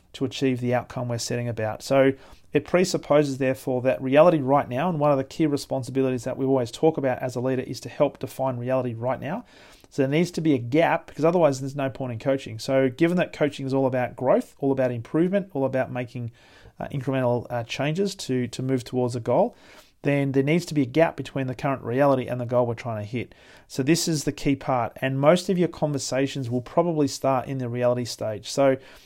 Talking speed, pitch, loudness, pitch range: 230 wpm, 135 Hz, -24 LUFS, 125-145 Hz